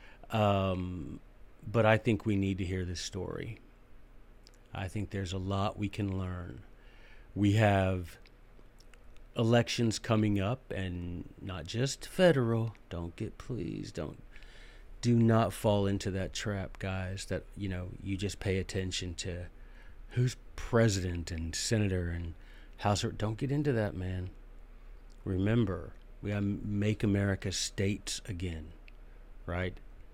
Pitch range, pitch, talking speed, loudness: 90-110 Hz, 95 Hz, 130 wpm, -33 LUFS